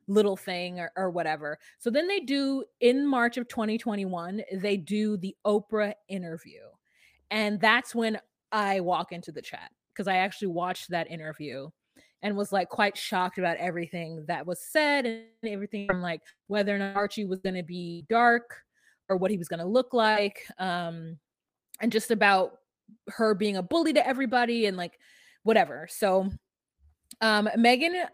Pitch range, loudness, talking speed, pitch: 180-225 Hz, -28 LUFS, 165 wpm, 205 Hz